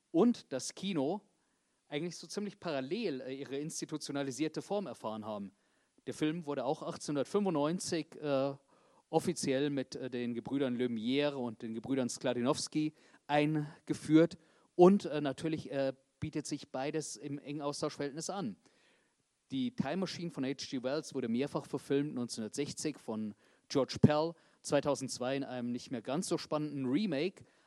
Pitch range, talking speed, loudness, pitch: 130-160 Hz, 130 wpm, -35 LUFS, 145 Hz